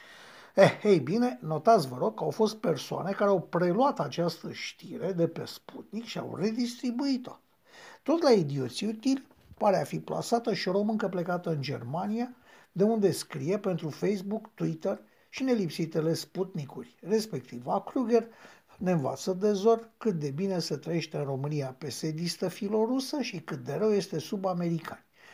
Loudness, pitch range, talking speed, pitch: -30 LUFS, 165-225 Hz, 155 wpm, 195 Hz